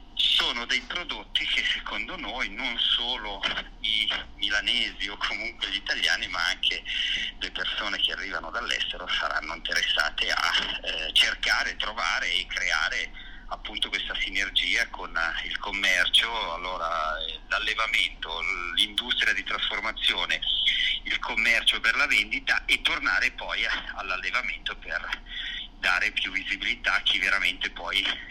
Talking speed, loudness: 120 wpm, -25 LUFS